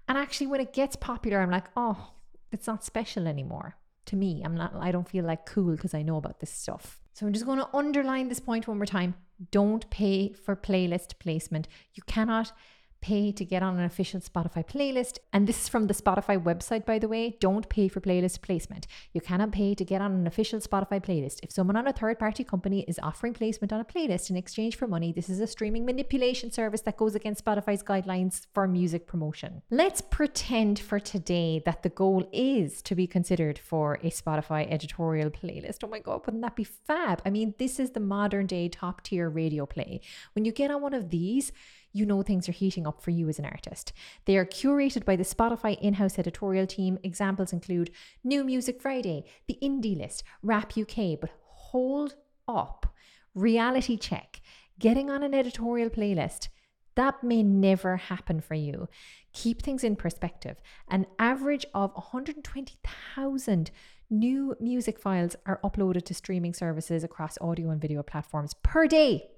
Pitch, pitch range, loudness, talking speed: 200 Hz, 175-230 Hz, -29 LUFS, 190 wpm